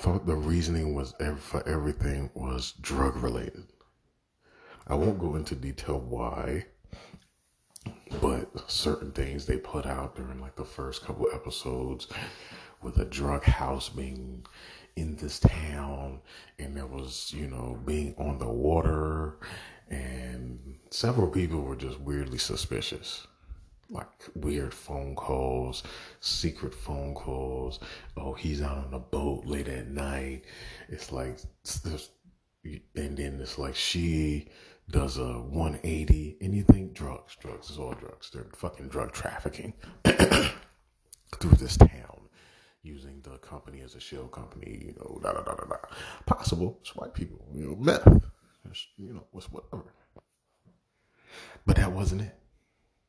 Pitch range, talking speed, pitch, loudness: 65-80 Hz, 140 wpm, 70 Hz, -30 LUFS